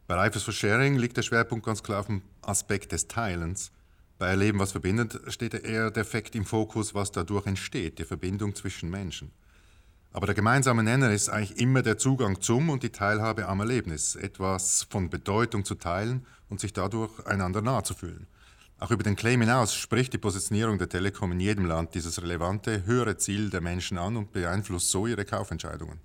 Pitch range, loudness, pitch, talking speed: 95-115 Hz, -28 LUFS, 100 Hz, 190 wpm